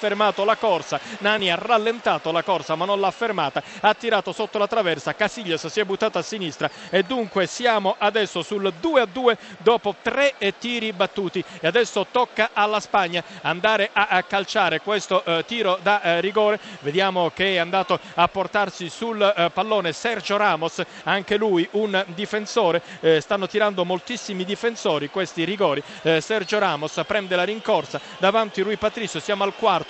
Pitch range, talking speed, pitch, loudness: 180-215 Hz, 155 wpm, 200 Hz, -22 LUFS